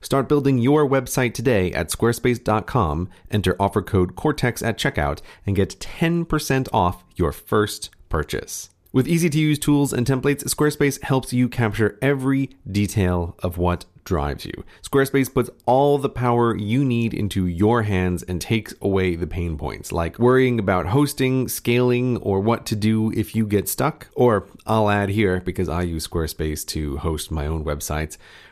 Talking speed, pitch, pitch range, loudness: 165 wpm, 110 Hz, 90-130 Hz, -21 LUFS